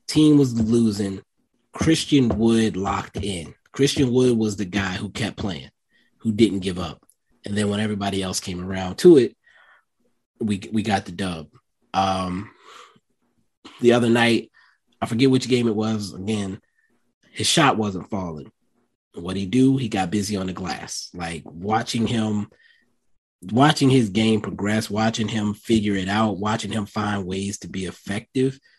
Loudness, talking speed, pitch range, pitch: -22 LUFS, 160 wpm, 95-115 Hz, 105 Hz